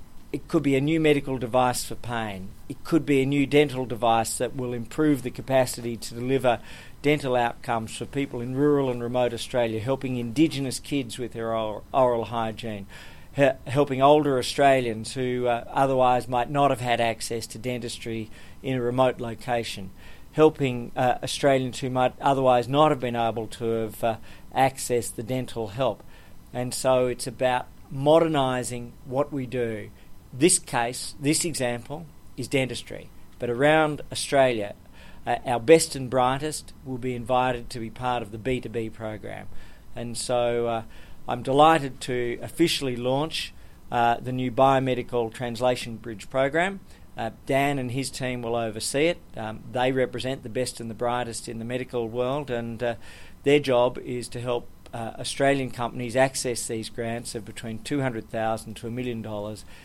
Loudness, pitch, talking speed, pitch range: -25 LUFS, 125 Hz, 165 wpm, 115-135 Hz